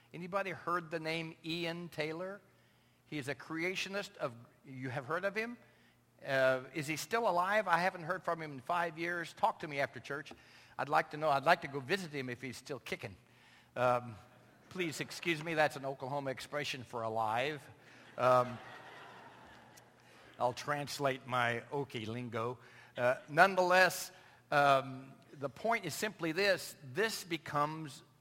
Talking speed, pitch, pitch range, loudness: 160 wpm, 145 Hz, 130-170 Hz, -35 LUFS